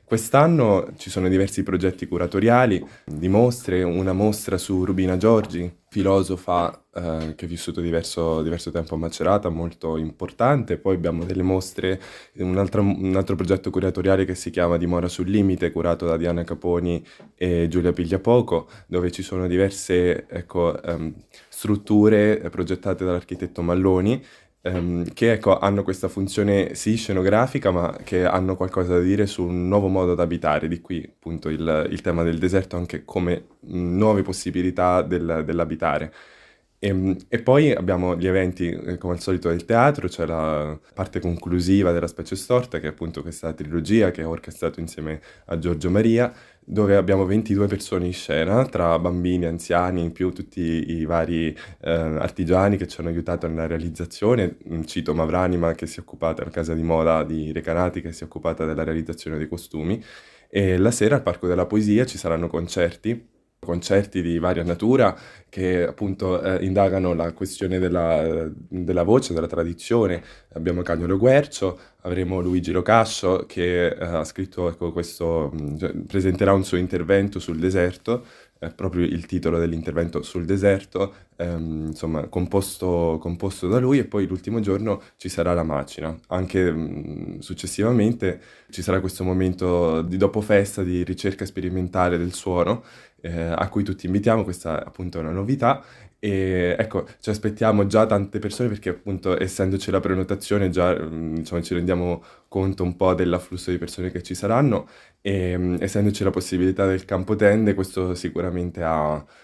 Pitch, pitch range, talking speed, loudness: 90 Hz, 85-95 Hz, 160 wpm, -23 LUFS